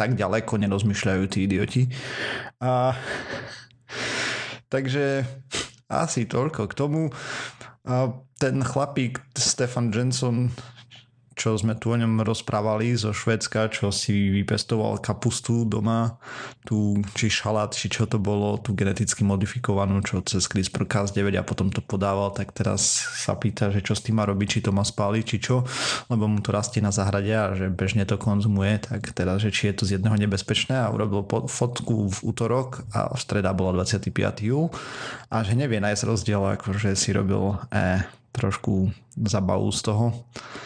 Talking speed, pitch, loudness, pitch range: 160 wpm, 110 Hz, -25 LUFS, 100-120 Hz